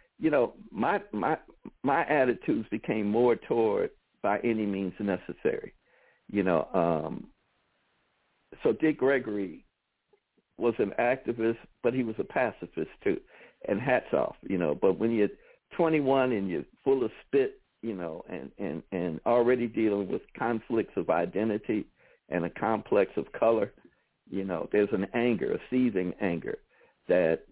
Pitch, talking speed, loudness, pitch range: 115 Hz, 145 wpm, -29 LUFS, 105-140 Hz